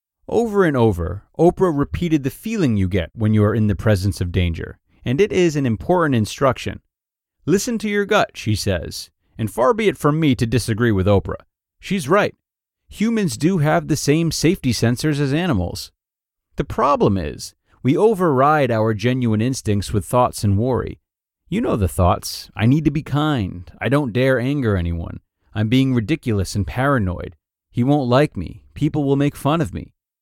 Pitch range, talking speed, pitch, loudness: 100-150 Hz, 180 wpm, 120 Hz, -19 LUFS